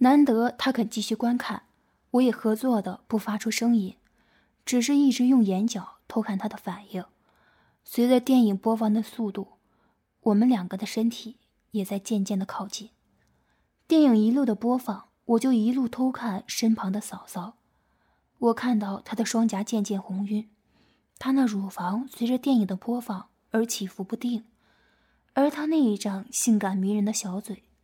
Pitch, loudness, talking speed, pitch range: 225 Hz, -26 LUFS, 240 characters per minute, 205-245 Hz